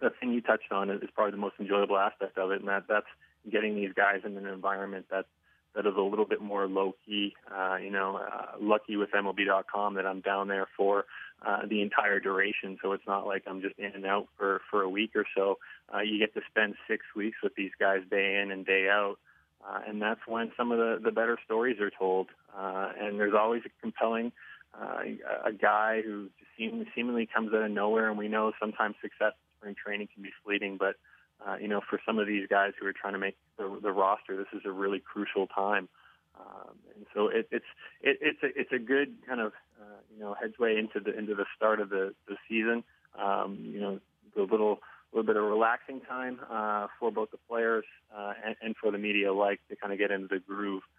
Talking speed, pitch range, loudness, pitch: 225 wpm, 100-110 Hz, -31 LUFS, 100 Hz